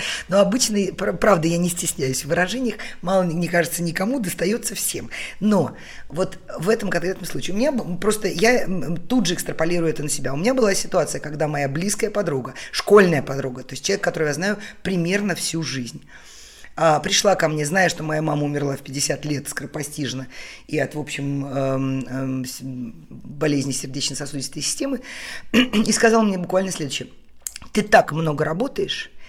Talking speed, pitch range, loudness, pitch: 160 wpm, 145-200 Hz, -21 LUFS, 170 Hz